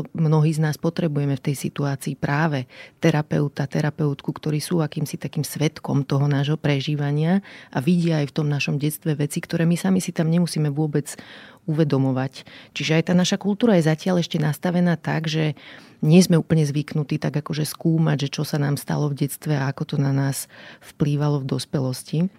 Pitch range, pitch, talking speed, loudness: 145-165 Hz, 155 Hz, 180 wpm, -22 LUFS